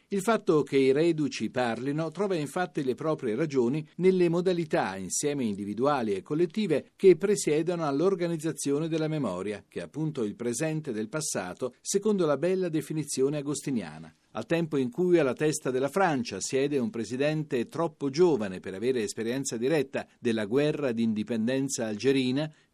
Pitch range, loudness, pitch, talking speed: 125-170 Hz, -28 LUFS, 150 Hz, 145 wpm